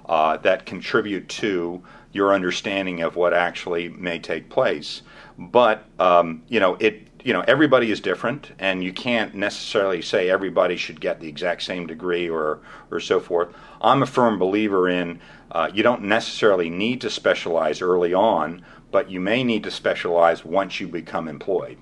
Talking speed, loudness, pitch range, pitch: 170 wpm, -22 LUFS, 85-90 Hz, 90 Hz